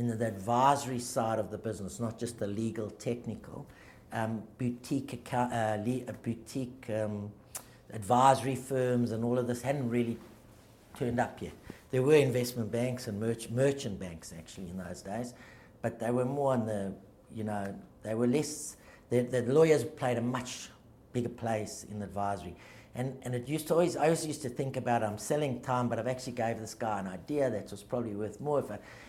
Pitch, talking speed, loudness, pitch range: 120 Hz, 195 wpm, -33 LUFS, 110-125 Hz